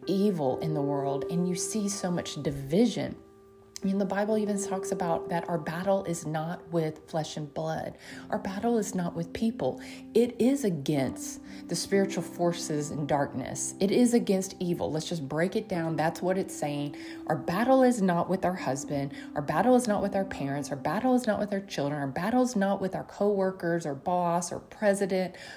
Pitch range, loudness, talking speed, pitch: 155-200 Hz, -29 LUFS, 200 wpm, 180 Hz